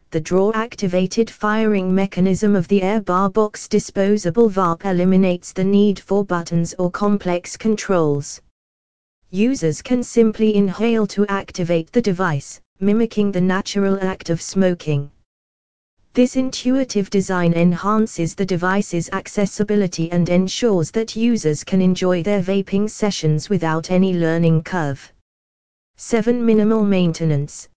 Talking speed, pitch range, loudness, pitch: 120 wpm, 170-210 Hz, -19 LUFS, 190 Hz